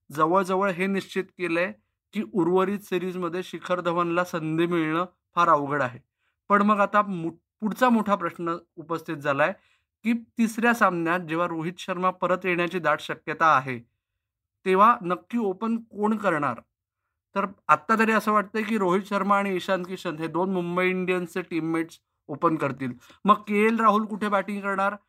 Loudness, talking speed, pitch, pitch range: -25 LUFS, 150 wpm, 185 Hz, 170-205 Hz